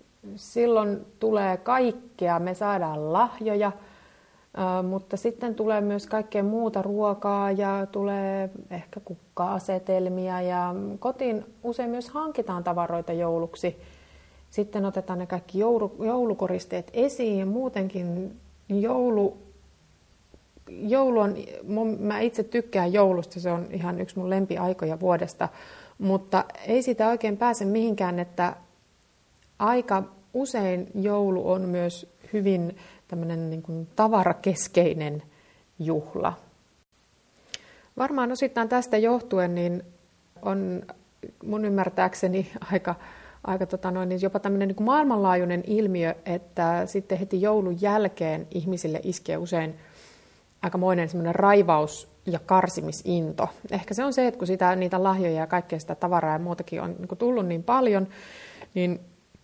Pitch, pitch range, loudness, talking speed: 190 Hz, 175-215 Hz, -26 LUFS, 115 wpm